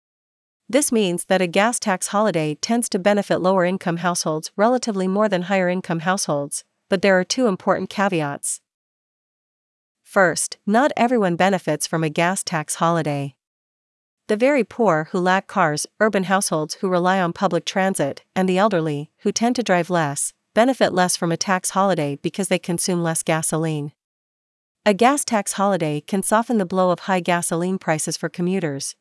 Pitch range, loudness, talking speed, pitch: 165-200 Hz, -20 LUFS, 165 wpm, 185 Hz